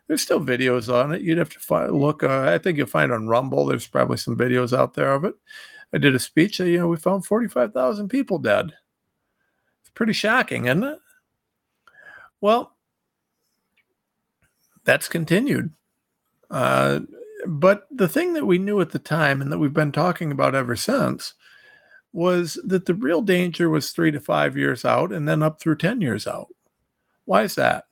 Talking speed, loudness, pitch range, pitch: 185 wpm, -21 LUFS, 145-220 Hz, 170 Hz